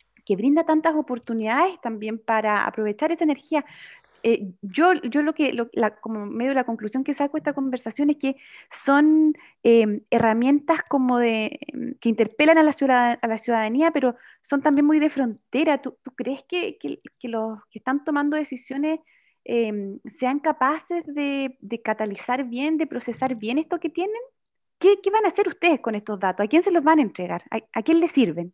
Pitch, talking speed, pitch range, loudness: 265 Hz, 195 wpm, 230-310 Hz, -23 LUFS